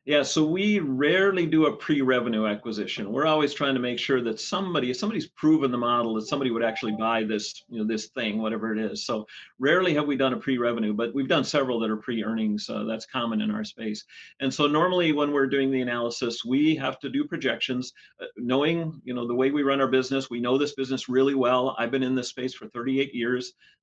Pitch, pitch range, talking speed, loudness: 130 Hz, 120-145 Hz, 230 wpm, -26 LUFS